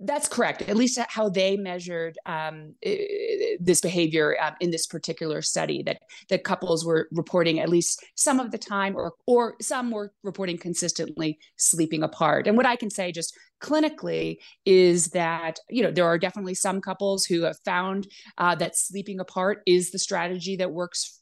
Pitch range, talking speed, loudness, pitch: 170-205 Hz, 175 wpm, -25 LUFS, 185 Hz